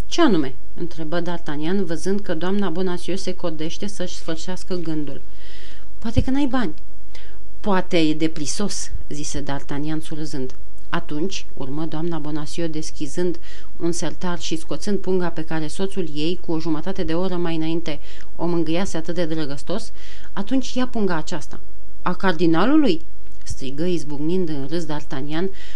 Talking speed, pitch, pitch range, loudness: 140 wpm, 170 Hz, 155-185 Hz, -25 LUFS